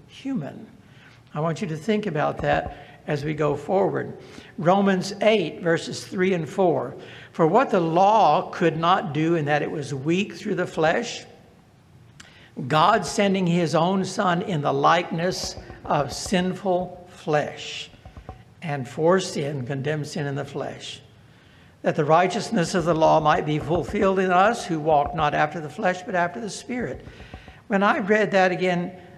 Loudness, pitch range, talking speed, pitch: -23 LUFS, 150-190 Hz, 160 wpm, 175 Hz